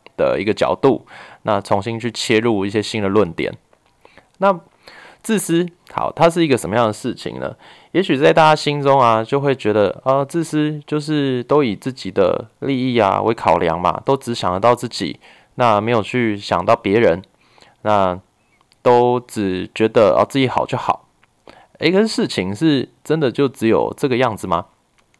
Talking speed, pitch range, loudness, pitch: 250 characters per minute, 110-145 Hz, -17 LUFS, 120 Hz